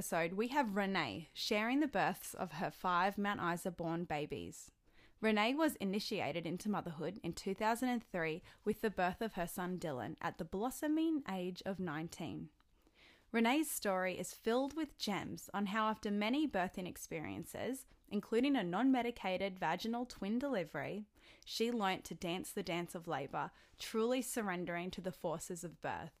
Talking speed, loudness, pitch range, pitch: 155 wpm, -39 LUFS, 175-230 Hz, 195 Hz